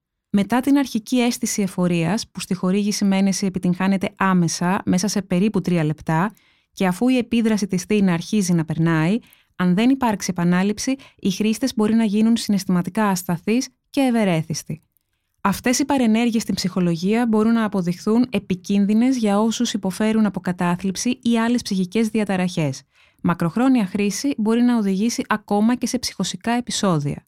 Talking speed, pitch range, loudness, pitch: 145 wpm, 185-230 Hz, -20 LUFS, 205 Hz